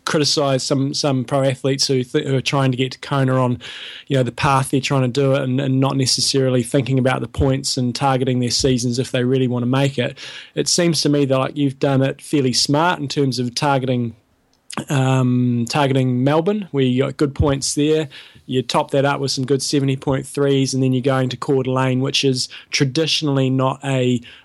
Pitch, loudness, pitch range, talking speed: 135 Hz, -18 LUFS, 130-140 Hz, 215 wpm